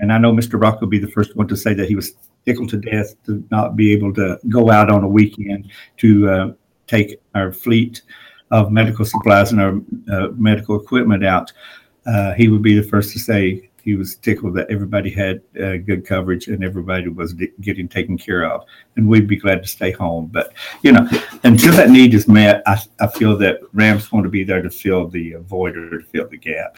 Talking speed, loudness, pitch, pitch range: 225 wpm, -15 LUFS, 105 Hz, 95-110 Hz